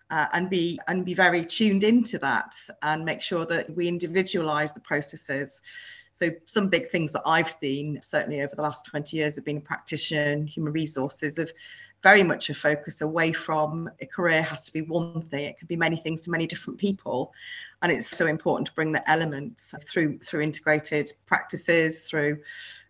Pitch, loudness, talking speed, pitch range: 160 Hz, -26 LUFS, 190 wpm, 150-170 Hz